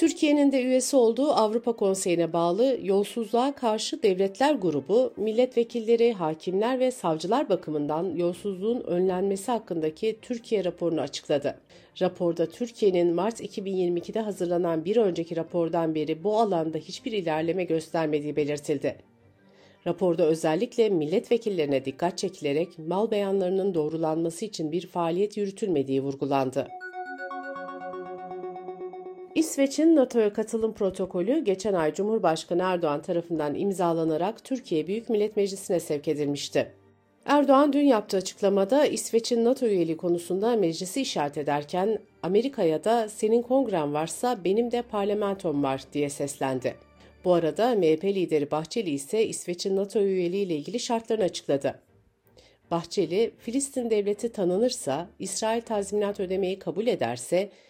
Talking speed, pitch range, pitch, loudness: 115 wpm, 165-230 Hz, 190 Hz, -26 LUFS